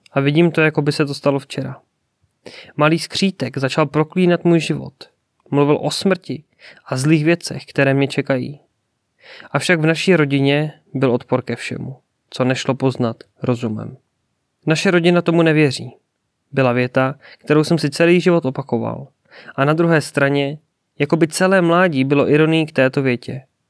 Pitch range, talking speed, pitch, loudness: 130-160 Hz, 155 wpm, 145 Hz, -17 LUFS